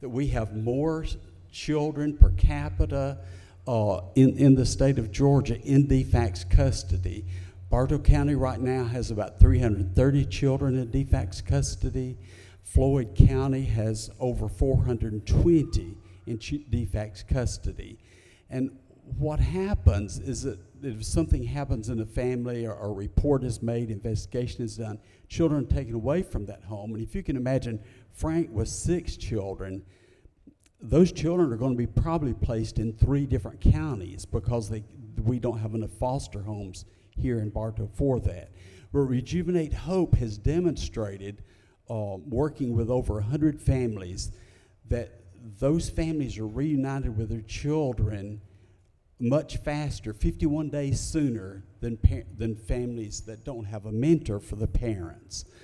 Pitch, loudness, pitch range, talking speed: 115 Hz, -27 LUFS, 100-130 Hz, 145 wpm